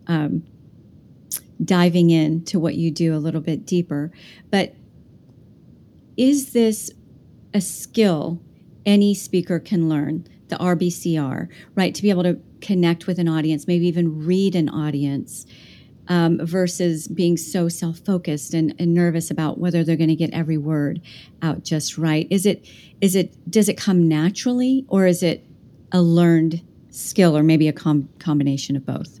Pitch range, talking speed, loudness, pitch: 160-185 Hz, 155 wpm, -20 LUFS, 170 Hz